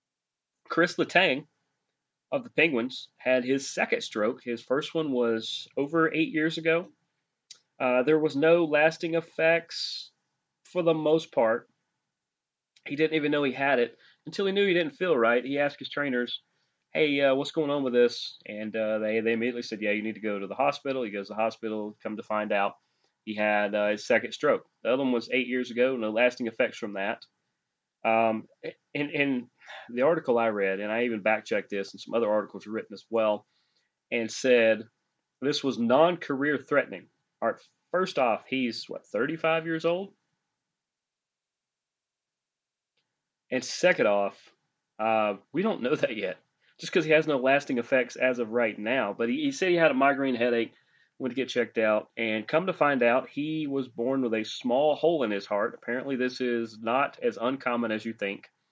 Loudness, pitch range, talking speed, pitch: -27 LUFS, 110-150 Hz, 190 wpm, 125 Hz